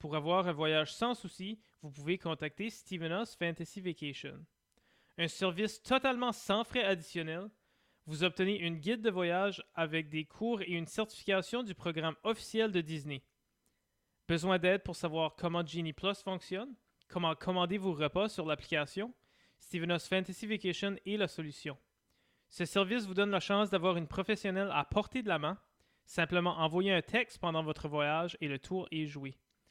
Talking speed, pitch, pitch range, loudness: 165 wpm, 180 Hz, 160-200 Hz, -35 LUFS